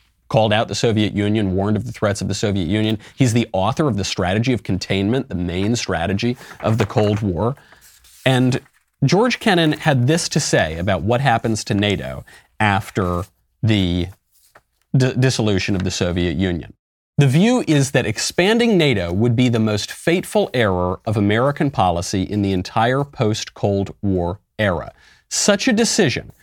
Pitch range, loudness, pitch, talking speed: 95-130 Hz, -19 LUFS, 110 Hz, 165 wpm